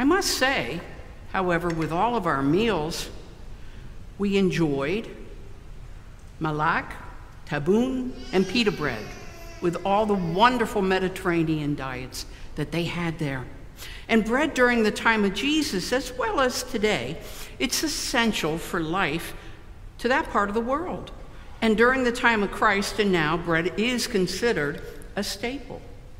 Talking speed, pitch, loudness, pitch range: 135 wpm, 200 Hz, -24 LUFS, 165-240 Hz